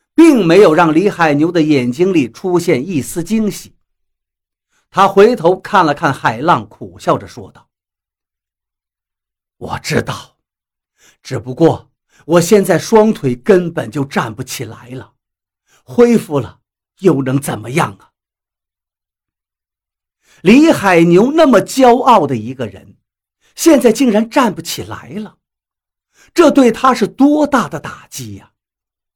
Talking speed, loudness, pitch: 180 characters per minute, -12 LUFS, 145 Hz